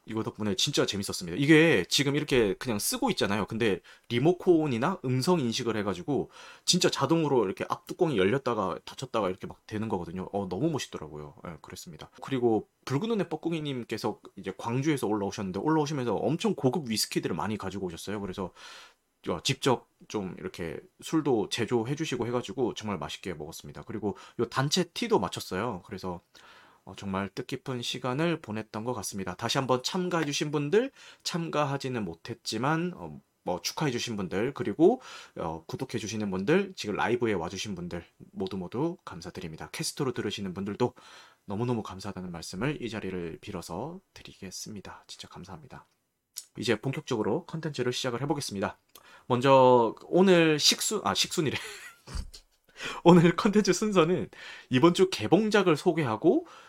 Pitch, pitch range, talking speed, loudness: 130 Hz, 105-165 Hz, 380 characters per minute, -28 LUFS